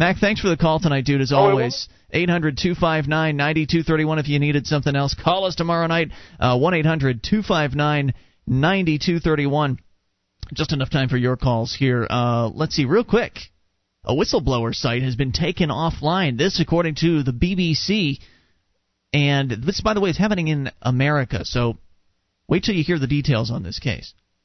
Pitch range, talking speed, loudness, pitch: 125-165 Hz, 200 wpm, -20 LUFS, 145 Hz